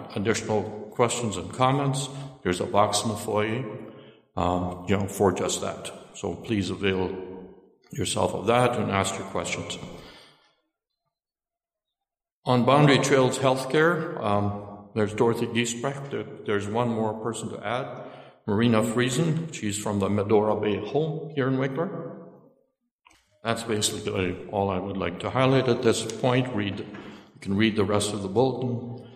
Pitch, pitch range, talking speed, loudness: 110 Hz, 105-130 Hz, 150 wpm, -26 LUFS